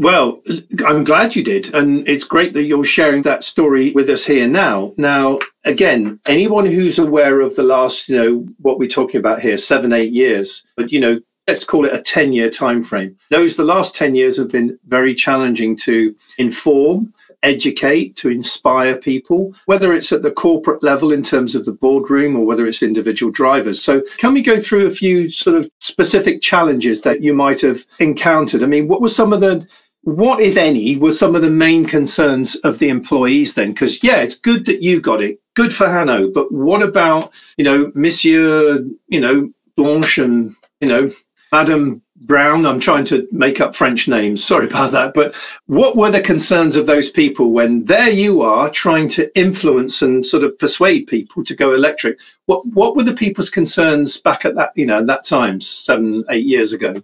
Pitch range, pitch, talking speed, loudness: 130-180 Hz, 150 Hz, 200 wpm, -14 LUFS